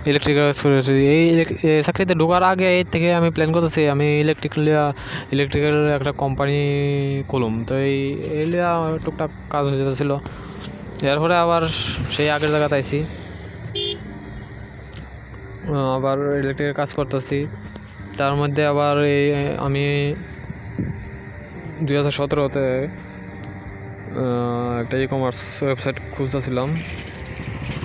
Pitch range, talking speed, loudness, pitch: 135-150 Hz, 105 wpm, -20 LUFS, 140 Hz